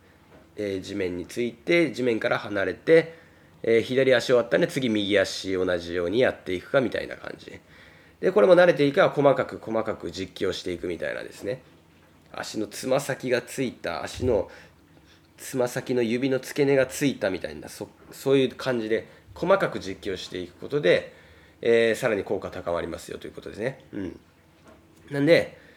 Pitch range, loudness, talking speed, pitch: 90-135 Hz, -25 LUFS, 345 characters per minute, 115 Hz